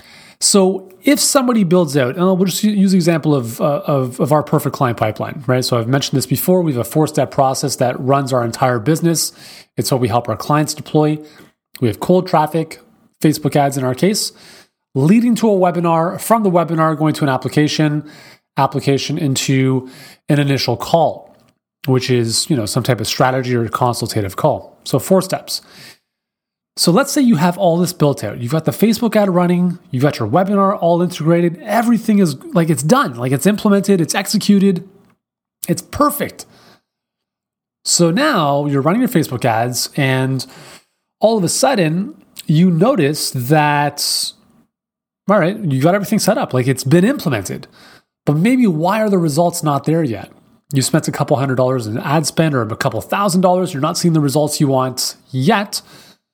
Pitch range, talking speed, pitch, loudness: 135-185 Hz, 180 wpm, 155 Hz, -15 LUFS